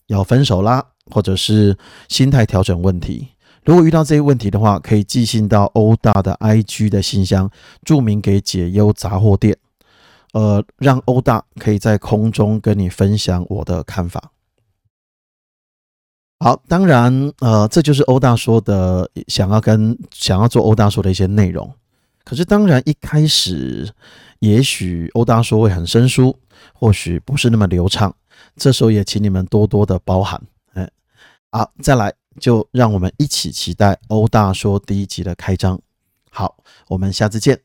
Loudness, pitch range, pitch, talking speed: -15 LUFS, 95-120 Hz, 105 Hz, 235 characters per minute